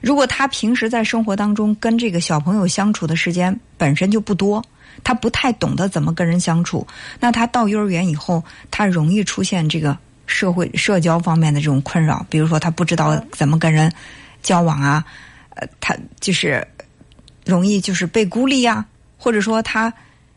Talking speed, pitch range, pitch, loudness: 275 characters per minute, 160-220 Hz, 180 Hz, -18 LUFS